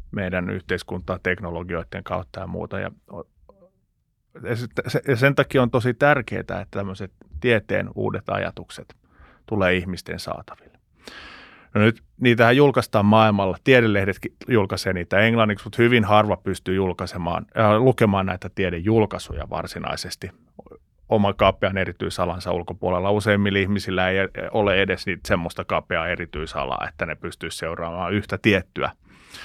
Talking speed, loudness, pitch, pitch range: 115 wpm, -22 LUFS, 100 Hz, 90-110 Hz